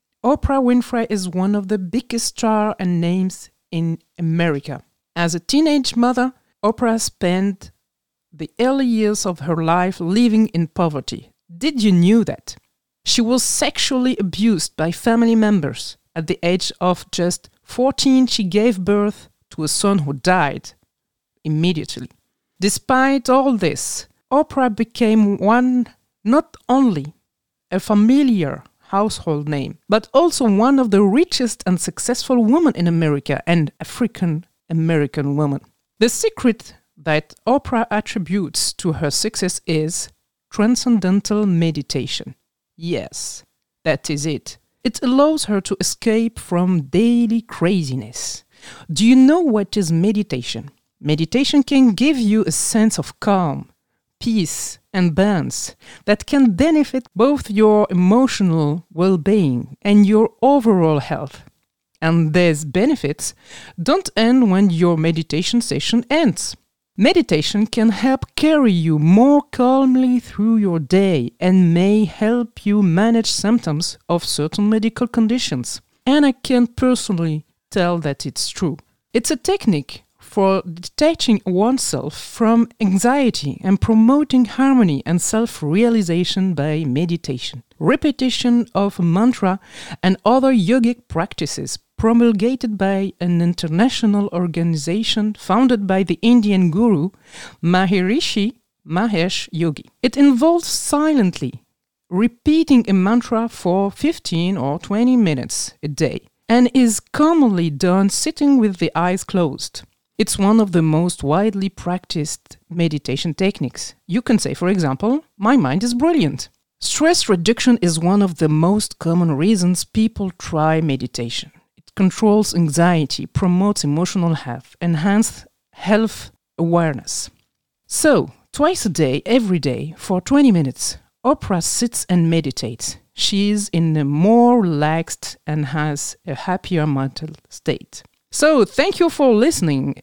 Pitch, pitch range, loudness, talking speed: 200 Hz, 165-235 Hz, -17 LUFS, 125 wpm